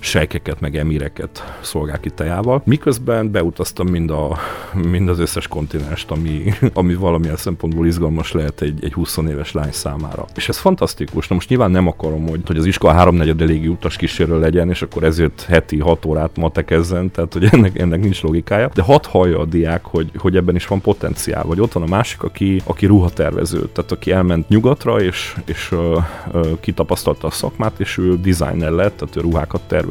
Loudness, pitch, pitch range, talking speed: -17 LUFS, 85 Hz, 80-95 Hz, 190 wpm